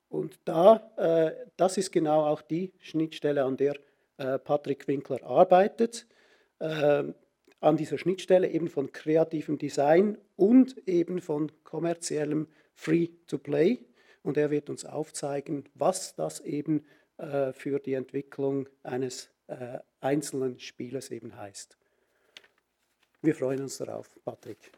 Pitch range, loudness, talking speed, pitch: 140-170 Hz, -28 LUFS, 125 wpm, 150 Hz